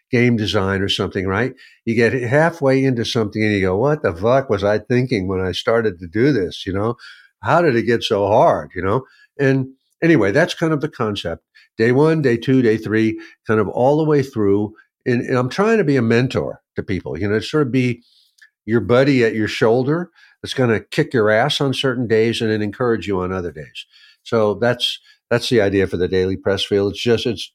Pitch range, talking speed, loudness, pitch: 105-130 Hz, 225 wpm, -18 LUFS, 115 Hz